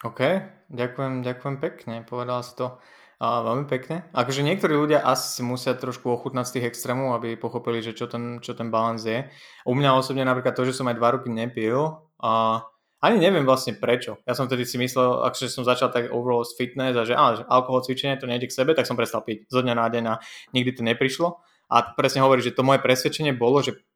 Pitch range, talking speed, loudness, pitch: 120-130 Hz, 225 wpm, -24 LUFS, 125 Hz